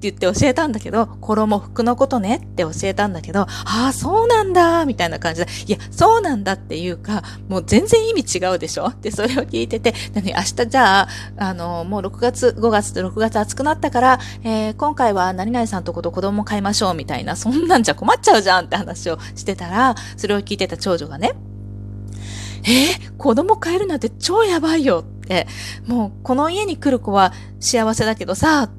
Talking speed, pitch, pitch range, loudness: 385 characters per minute, 215 Hz, 175-265 Hz, -18 LUFS